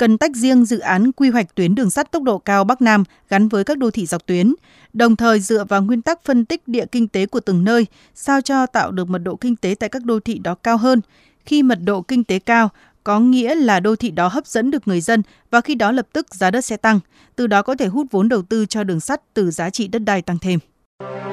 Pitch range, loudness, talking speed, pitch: 195-250 Hz, -17 LUFS, 265 wpm, 225 Hz